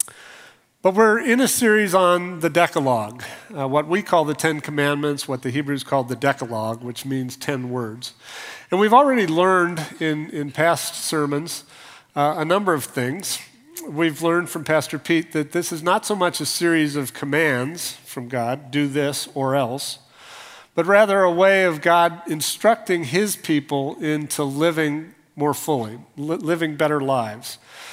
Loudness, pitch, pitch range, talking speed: -21 LUFS, 155 Hz, 140-175 Hz, 165 wpm